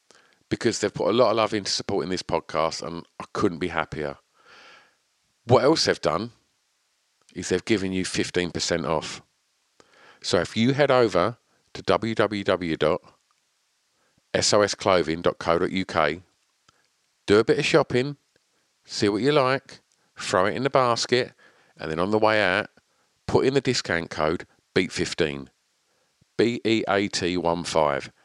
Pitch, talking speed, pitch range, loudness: 95 Hz, 125 wpm, 85-115 Hz, -24 LUFS